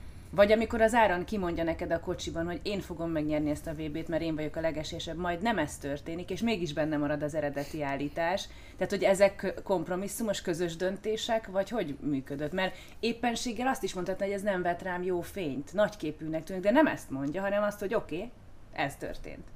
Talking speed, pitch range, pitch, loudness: 200 wpm, 160-200 Hz, 180 Hz, -31 LUFS